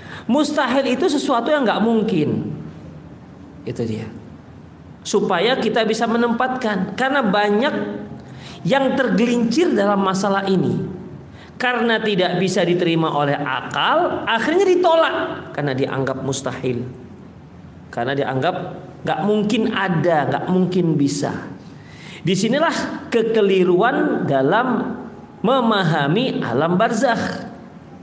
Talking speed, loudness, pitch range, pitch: 95 wpm, -19 LUFS, 160-235 Hz, 200 Hz